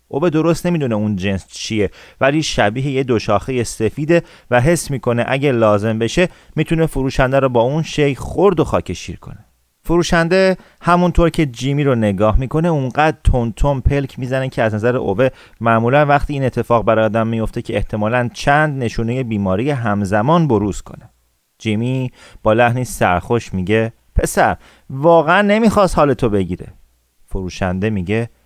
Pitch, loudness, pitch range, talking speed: 125 Hz, -16 LUFS, 110-150 Hz, 150 wpm